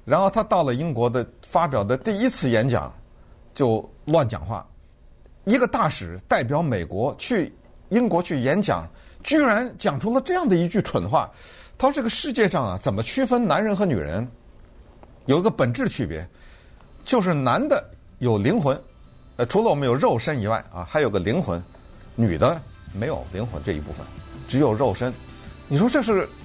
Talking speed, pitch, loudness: 250 characters per minute, 120 Hz, -23 LUFS